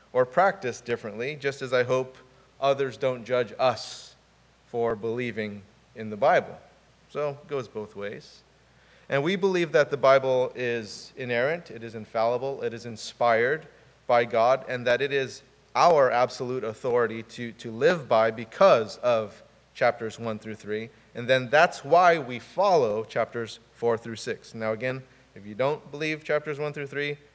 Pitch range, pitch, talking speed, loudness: 115-135 Hz, 125 Hz, 160 wpm, -26 LUFS